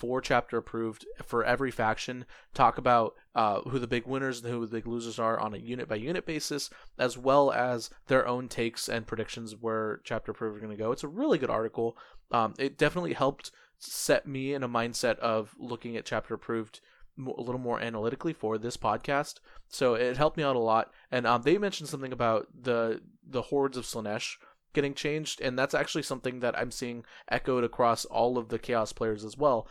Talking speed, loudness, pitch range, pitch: 210 wpm, -30 LUFS, 115-135 Hz, 120 Hz